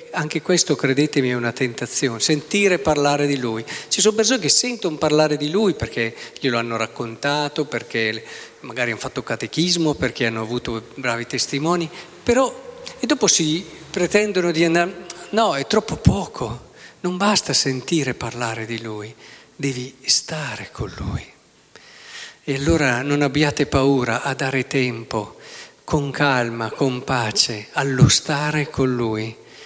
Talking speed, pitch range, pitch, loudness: 140 wpm, 120-165 Hz, 140 Hz, -20 LUFS